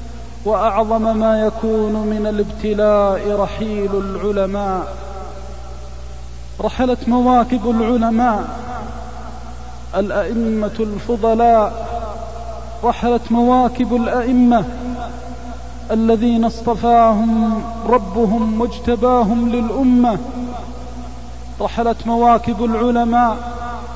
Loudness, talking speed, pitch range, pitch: -17 LUFS, 60 wpm, 205-240 Hz, 225 Hz